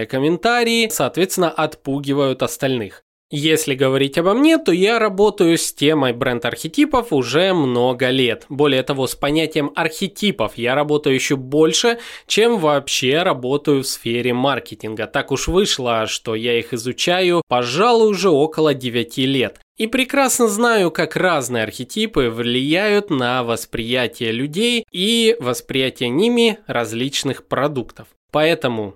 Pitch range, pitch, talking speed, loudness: 125-185 Hz, 145 Hz, 125 wpm, -18 LUFS